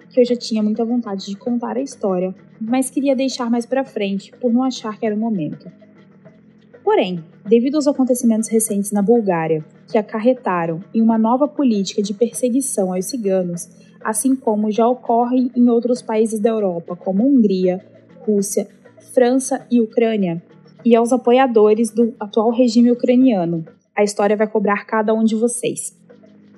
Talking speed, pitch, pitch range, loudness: 160 wpm, 220 Hz, 200-245 Hz, -18 LUFS